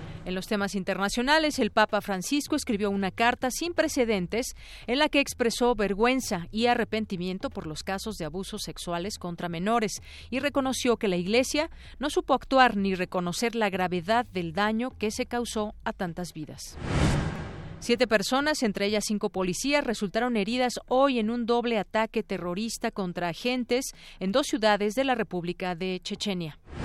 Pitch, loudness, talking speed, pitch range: 220 Hz, -27 LUFS, 160 wpm, 190-245 Hz